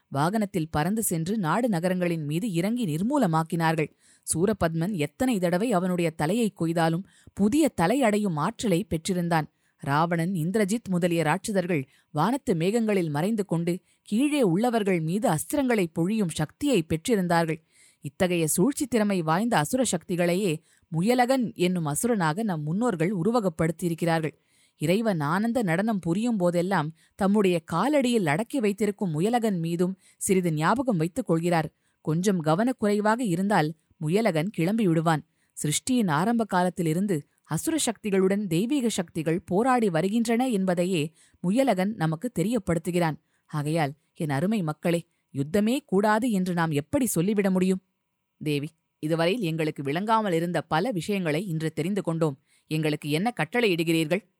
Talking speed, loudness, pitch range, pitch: 115 wpm, -26 LUFS, 165-215 Hz, 180 Hz